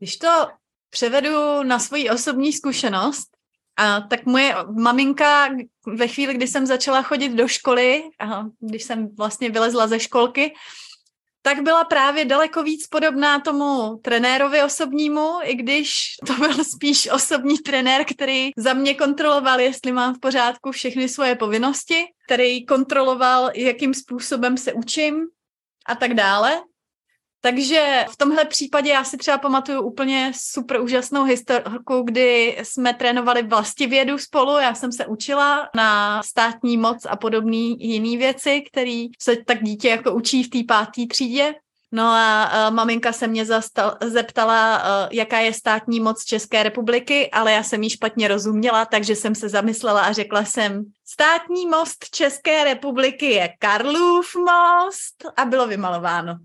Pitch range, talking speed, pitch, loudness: 225-285 Hz, 145 wpm, 255 Hz, -19 LUFS